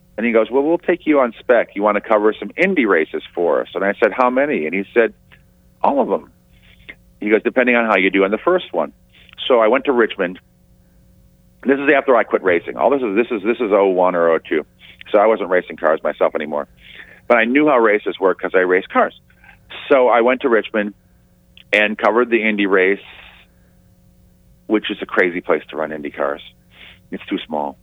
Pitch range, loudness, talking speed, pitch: 90-115 Hz, -17 LUFS, 220 wpm, 105 Hz